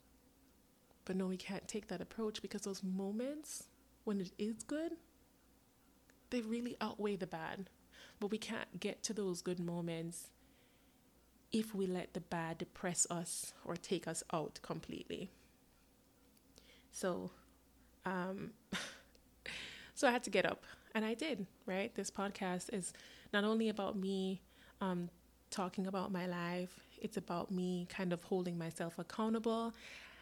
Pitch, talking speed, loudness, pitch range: 195 Hz, 140 wpm, -42 LUFS, 180-220 Hz